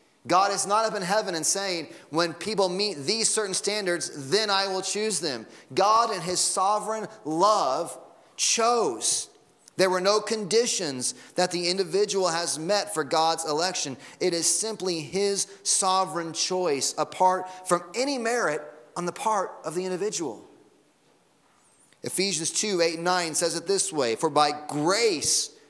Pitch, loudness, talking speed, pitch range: 185 Hz, -25 LUFS, 150 wpm, 165-205 Hz